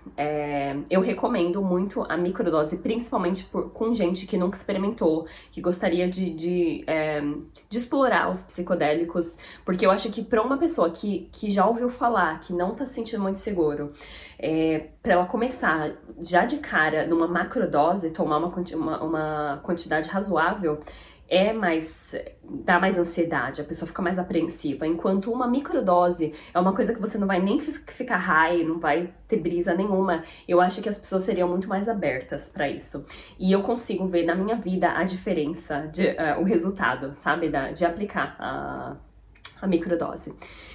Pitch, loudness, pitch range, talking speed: 175 Hz, -25 LUFS, 160-195 Hz, 170 wpm